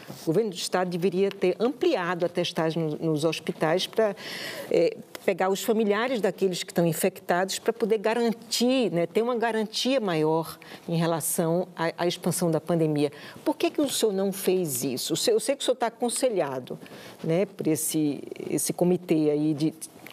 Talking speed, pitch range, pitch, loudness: 175 wpm, 165-220 Hz, 185 Hz, -26 LUFS